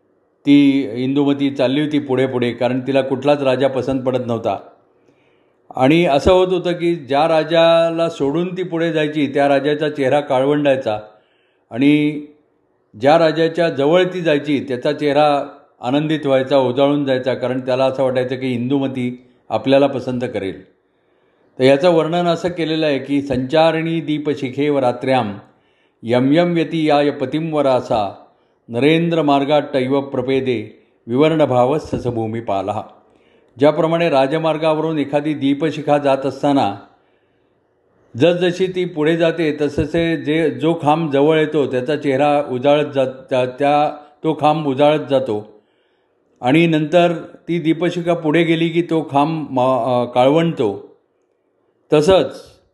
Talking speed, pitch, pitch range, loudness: 125 wpm, 145 Hz, 130-160 Hz, -17 LUFS